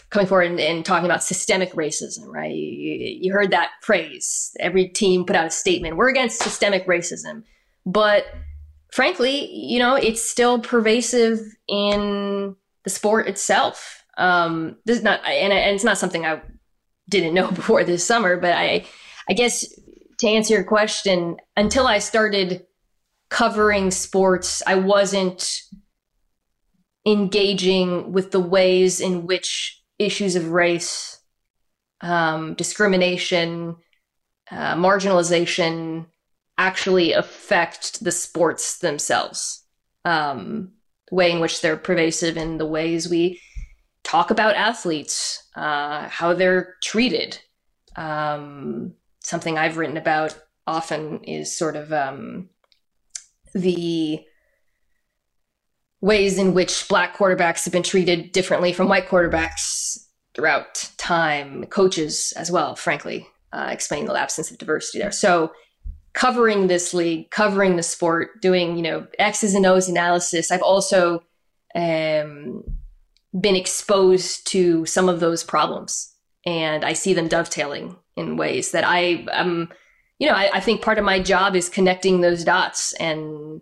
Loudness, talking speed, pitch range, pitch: -20 LUFS, 135 wpm, 170-200 Hz, 185 Hz